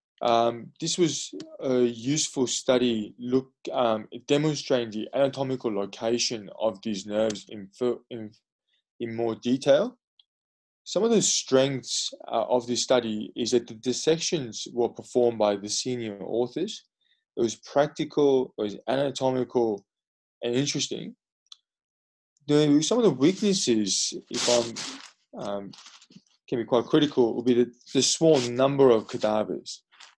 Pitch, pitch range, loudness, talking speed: 125 Hz, 115-140 Hz, -26 LUFS, 130 wpm